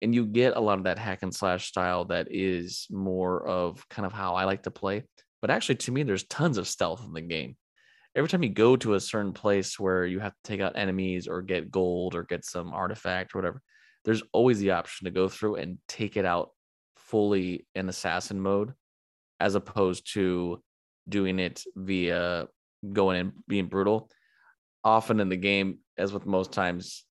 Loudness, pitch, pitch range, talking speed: -29 LUFS, 95 Hz, 90-100 Hz, 200 wpm